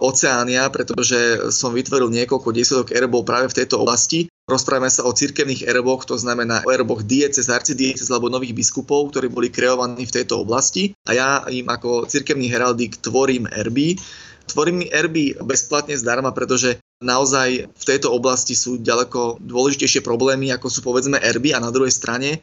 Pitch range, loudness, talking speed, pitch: 120-135 Hz, -18 LUFS, 160 wpm, 130 Hz